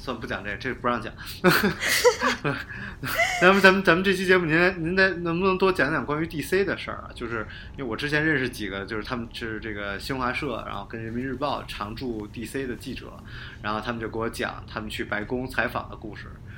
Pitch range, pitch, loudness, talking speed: 110-155 Hz, 120 Hz, -25 LUFS, 325 characters per minute